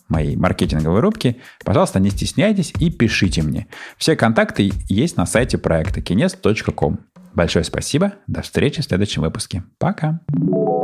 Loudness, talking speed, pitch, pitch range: -19 LUFS, 135 wpm, 100 Hz, 85-135 Hz